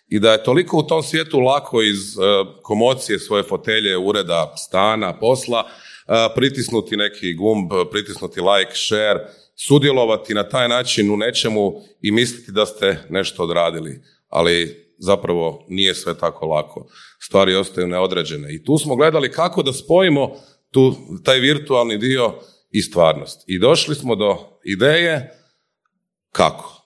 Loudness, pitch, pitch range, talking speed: -18 LUFS, 120 Hz, 100-145 Hz, 135 wpm